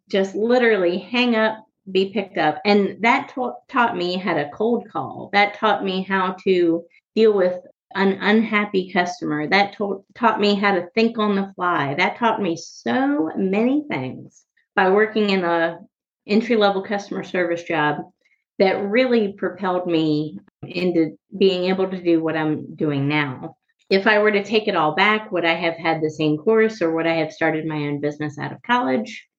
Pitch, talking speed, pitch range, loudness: 195 Hz, 185 wpm, 170-215 Hz, -20 LUFS